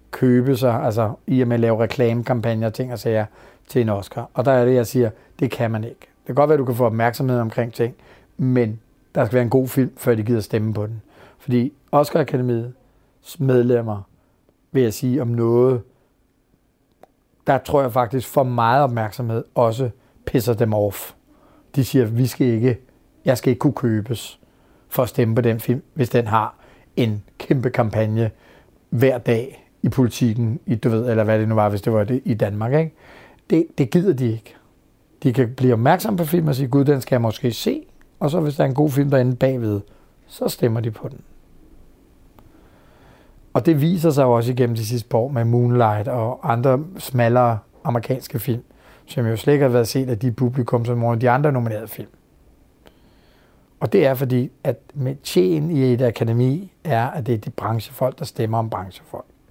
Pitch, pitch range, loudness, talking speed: 125 Hz, 115-135 Hz, -20 LUFS, 195 wpm